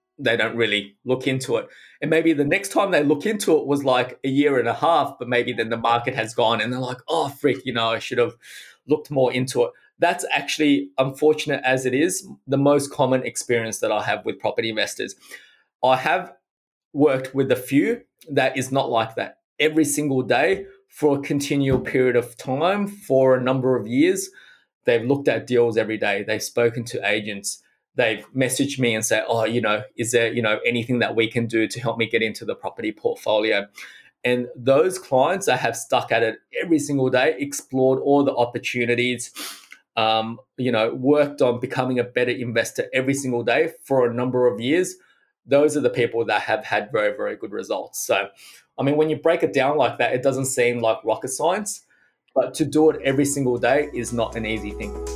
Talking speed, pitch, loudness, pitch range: 205 wpm, 130 Hz, -22 LUFS, 120-150 Hz